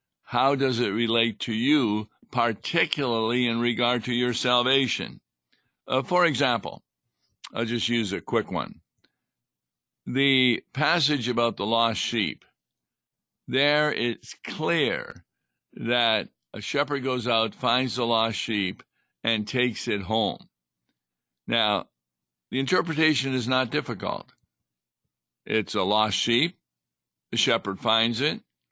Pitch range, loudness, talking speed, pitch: 105-130 Hz, -25 LUFS, 120 wpm, 115 Hz